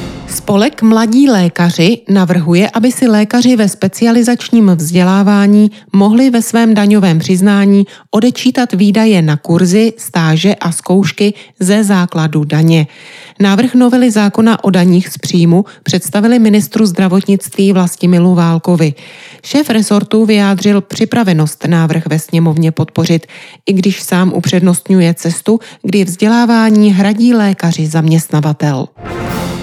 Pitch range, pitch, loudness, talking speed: 170-220 Hz, 195 Hz, -10 LUFS, 110 wpm